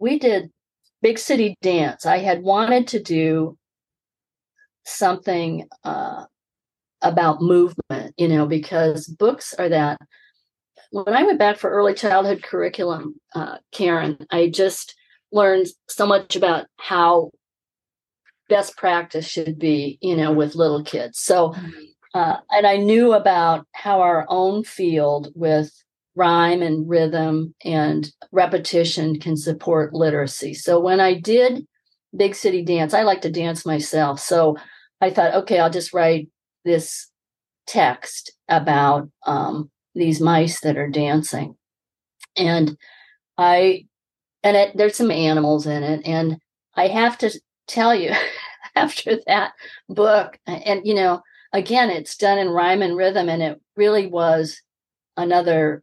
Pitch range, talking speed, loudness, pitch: 160-200 Hz, 135 wpm, -19 LUFS, 175 Hz